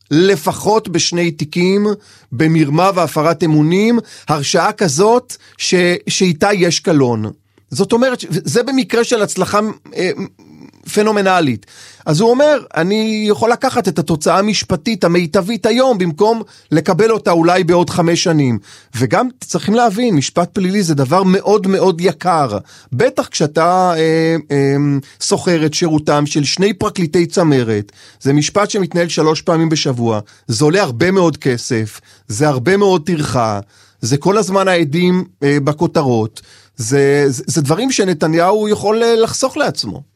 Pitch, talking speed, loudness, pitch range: 175 Hz, 130 wpm, -14 LUFS, 150-200 Hz